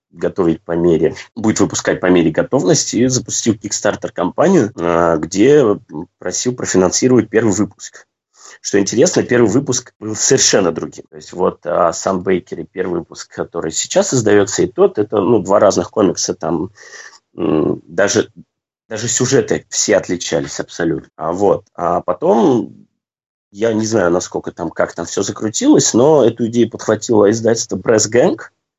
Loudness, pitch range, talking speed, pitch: -15 LUFS, 95-115 Hz, 145 wpm, 110 Hz